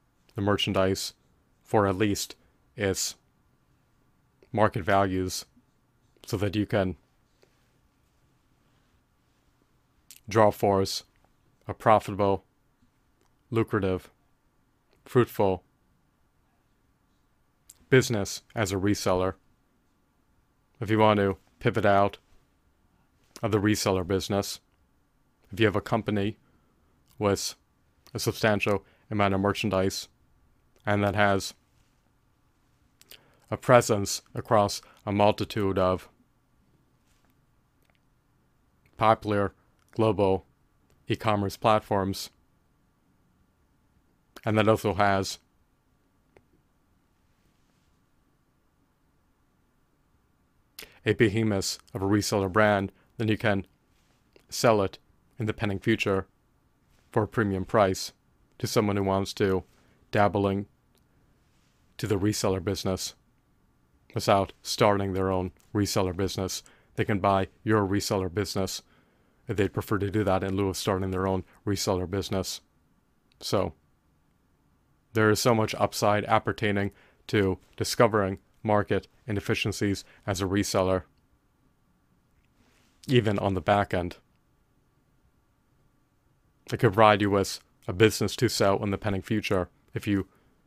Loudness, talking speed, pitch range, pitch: -27 LUFS, 100 wpm, 95-110 Hz, 100 Hz